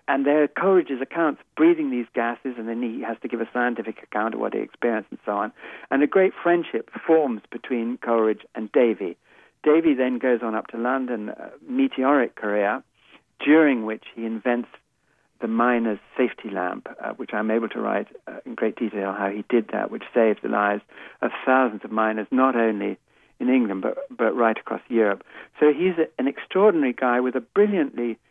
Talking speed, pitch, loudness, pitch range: 195 wpm, 125 Hz, -23 LUFS, 115-150 Hz